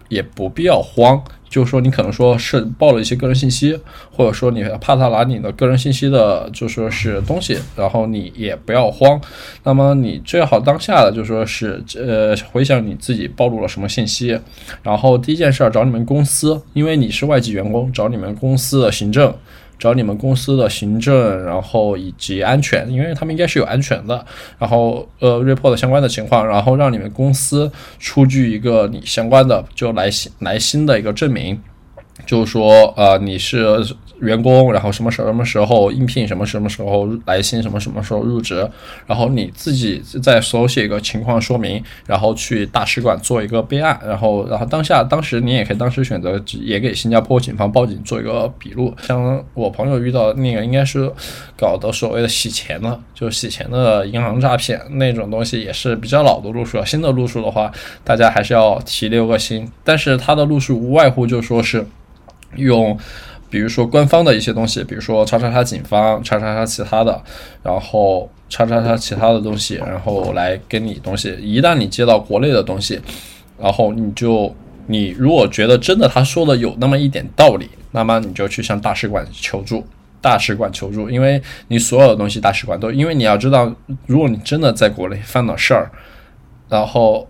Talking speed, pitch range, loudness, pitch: 310 characters per minute, 110-130 Hz, -15 LUFS, 115 Hz